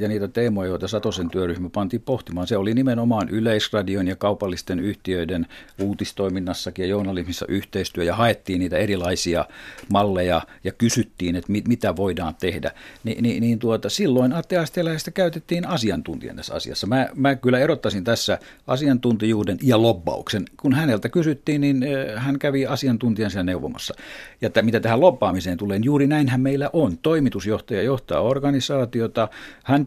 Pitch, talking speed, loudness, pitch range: 110 Hz, 145 wpm, -22 LUFS, 95-130 Hz